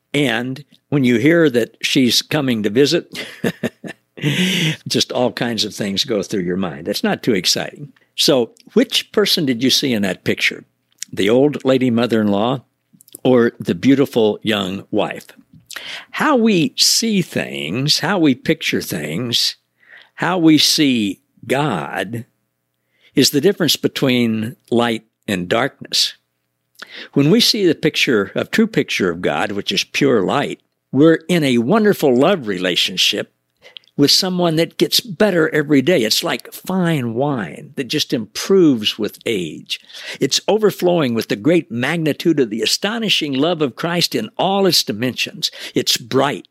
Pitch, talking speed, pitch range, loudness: 145 Hz, 150 wpm, 120-175 Hz, -16 LUFS